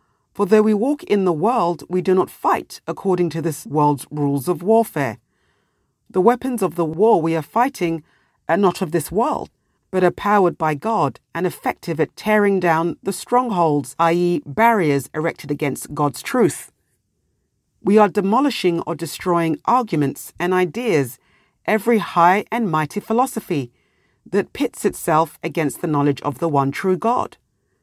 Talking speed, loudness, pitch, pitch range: 155 wpm, -19 LUFS, 175 Hz, 155-210 Hz